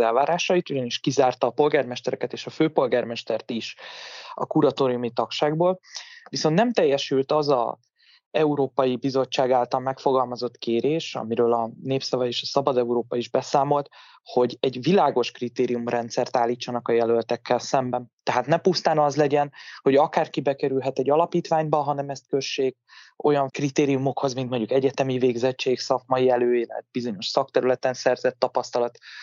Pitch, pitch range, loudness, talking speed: 135 Hz, 125-145 Hz, -24 LUFS, 130 wpm